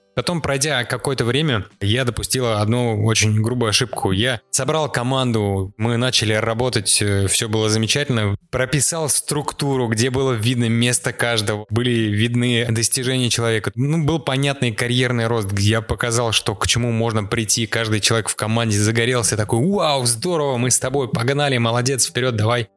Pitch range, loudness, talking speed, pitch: 110-130 Hz, -18 LUFS, 155 wpm, 120 Hz